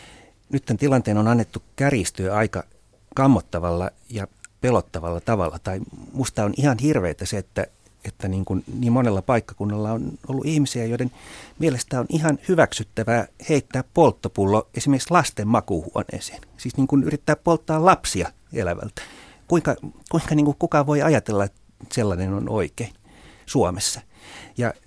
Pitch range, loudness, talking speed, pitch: 100-140 Hz, -22 LUFS, 140 wpm, 120 Hz